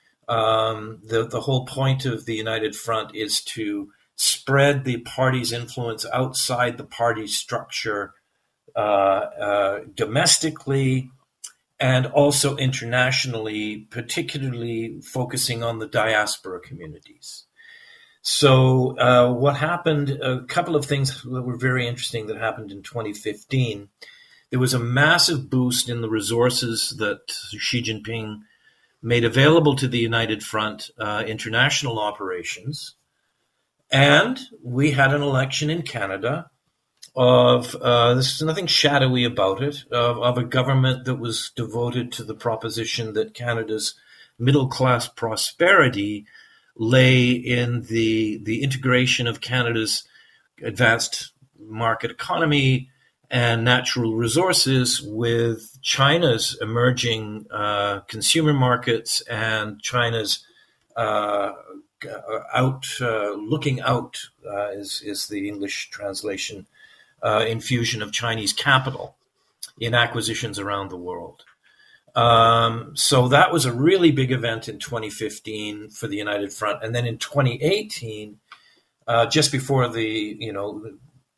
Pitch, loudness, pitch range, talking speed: 120 Hz, -21 LUFS, 110-135 Hz, 120 wpm